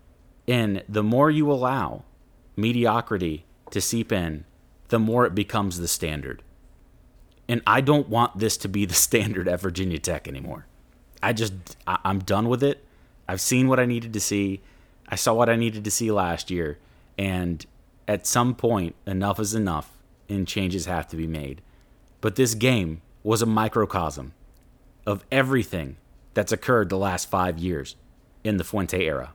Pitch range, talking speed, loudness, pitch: 90-115 Hz, 165 wpm, -24 LUFS, 100 Hz